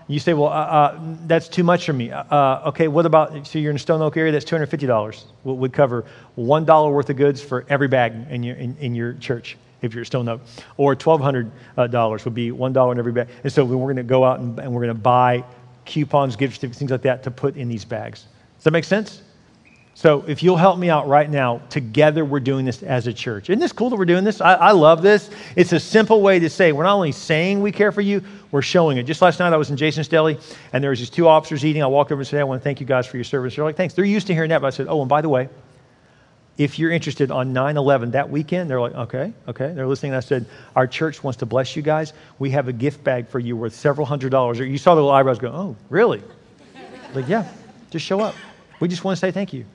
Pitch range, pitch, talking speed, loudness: 125-160 Hz, 140 Hz, 270 wpm, -19 LUFS